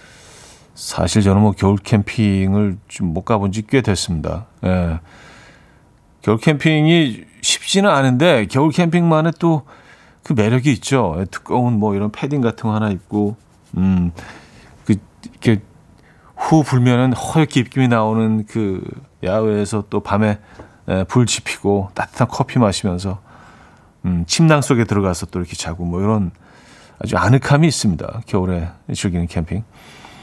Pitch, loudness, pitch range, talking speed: 105 Hz, -17 LUFS, 95-125 Hz, 270 characters per minute